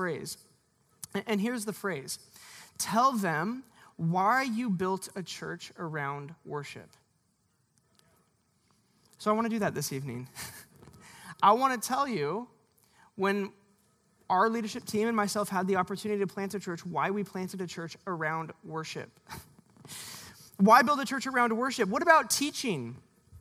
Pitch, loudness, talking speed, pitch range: 200 Hz, -30 LUFS, 145 wpm, 170-225 Hz